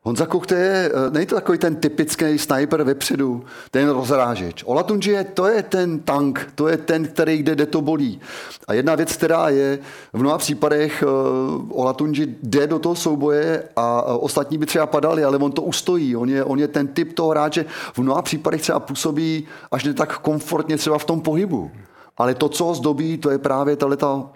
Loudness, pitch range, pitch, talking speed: -20 LUFS, 140-160 Hz, 150 Hz, 190 wpm